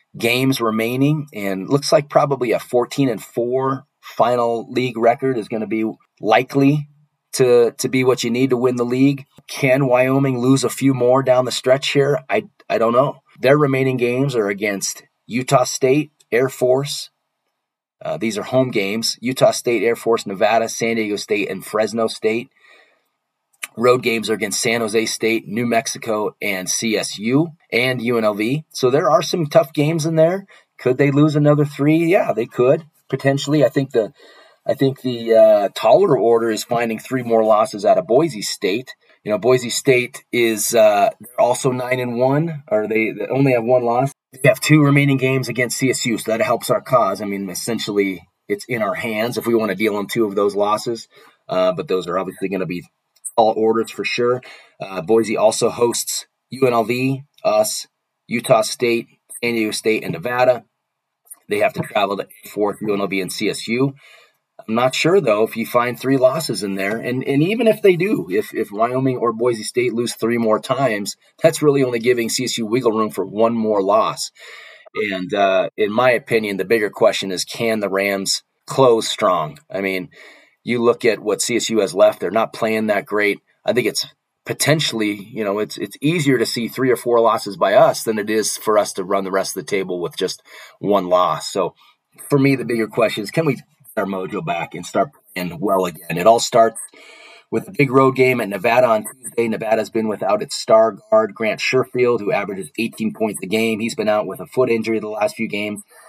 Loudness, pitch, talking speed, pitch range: -18 LUFS, 120 Hz, 195 wpm, 110-135 Hz